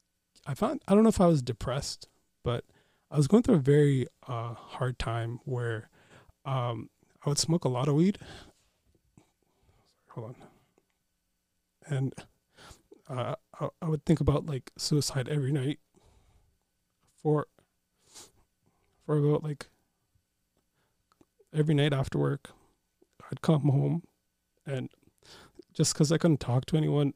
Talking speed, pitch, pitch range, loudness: 135 wpm, 145 Hz, 120-155 Hz, -29 LUFS